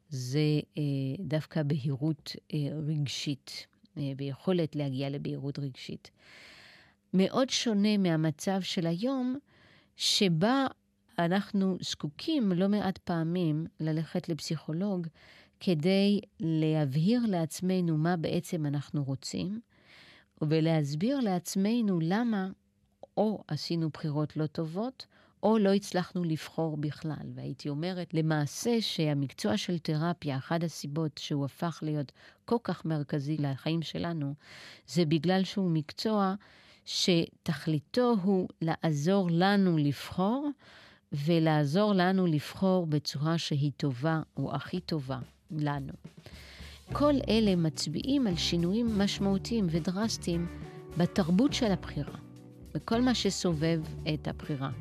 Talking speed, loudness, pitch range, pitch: 105 wpm, -31 LUFS, 150-190 Hz, 165 Hz